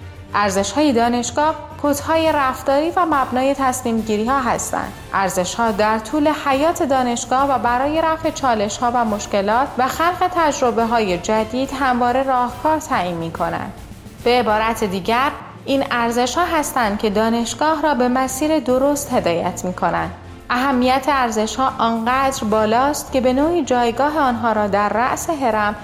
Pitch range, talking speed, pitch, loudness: 220-280 Hz, 125 wpm, 250 Hz, -18 LUFS